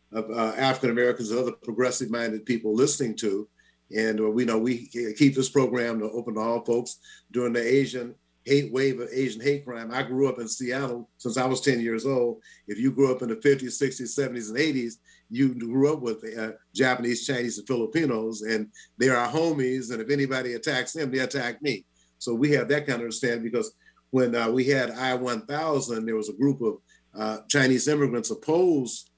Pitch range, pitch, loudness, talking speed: 115-135 Hz, 125 Hz, -26 LUFS, 200 wpm